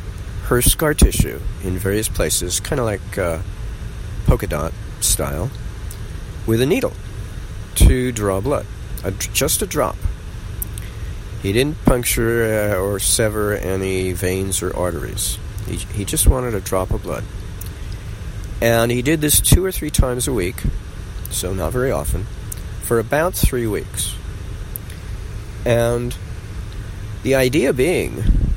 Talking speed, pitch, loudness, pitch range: 130 wpm, 100 Hz, -19 LUFS, 95-115 Hz